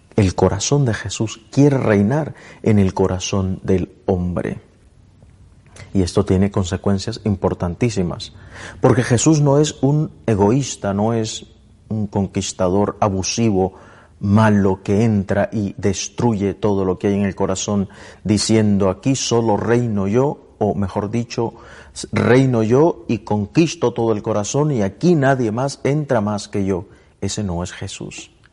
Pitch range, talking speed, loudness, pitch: 100-115 Hz, 140 wpm, -18 LUFS, 105 Hz